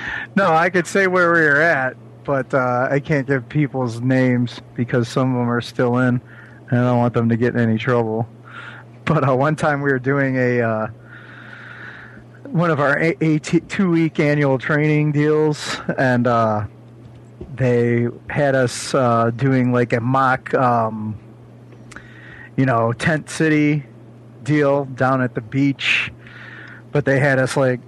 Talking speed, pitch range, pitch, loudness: 165 wpm, 120-145 Hz, 125 Hz, -18 LUFS